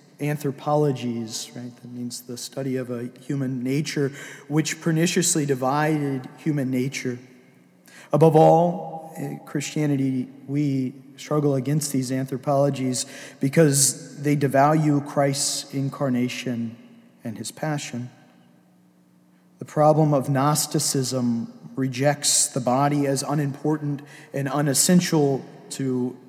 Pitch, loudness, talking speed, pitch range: 140 Hz, -23 LUFS, 100 wpm, 130-150 Hz